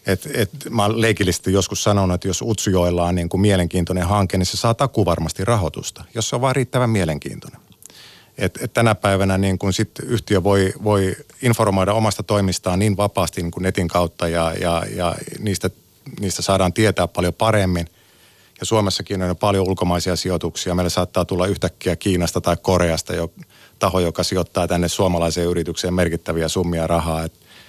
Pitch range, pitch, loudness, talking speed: 90-105 Hz, 95 Hz, -20 LUFS, 165 wpm